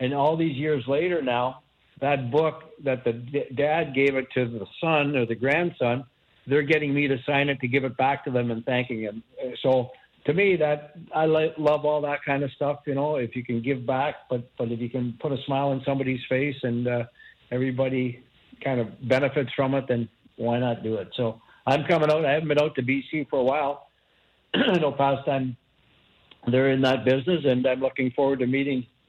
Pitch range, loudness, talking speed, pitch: 125-145 Hz, -25 LUFS, 210 wpm, 135 Hz